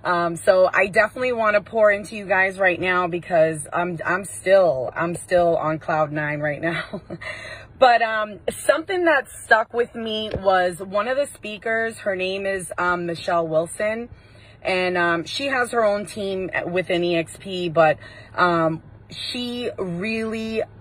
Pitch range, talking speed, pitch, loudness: 170-220 Hz, 155 wpm, 190 Hz, -21 LUFS